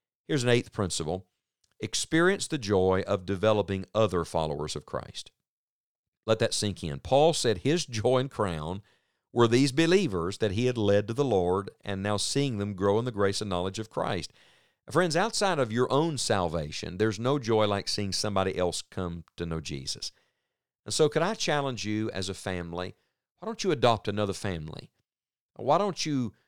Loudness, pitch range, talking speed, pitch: -28 LUFS, 95-135 Hz, 185 wpm, 105 Hz